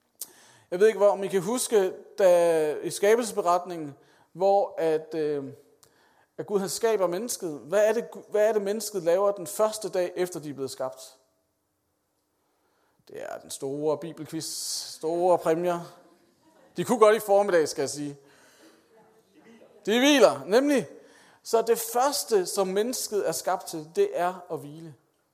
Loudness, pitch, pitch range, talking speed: -25 LUFS, 180 Hz, 155-215 Hz, 150 wpm